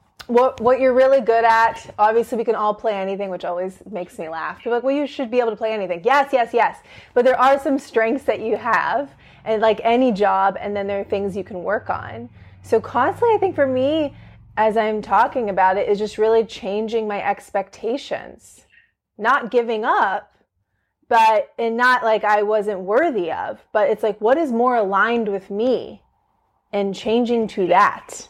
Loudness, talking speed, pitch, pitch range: -19 LUFS, 195 wpm, 225 Hz, 200-250 Hz